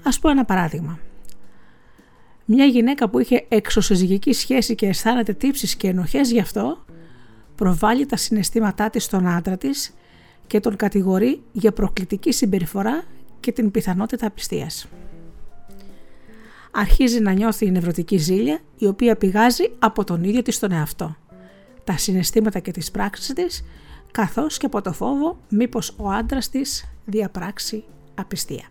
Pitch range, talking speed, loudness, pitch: 185-240 Hz, 140 wpm, -21 LUFS, 210 Hz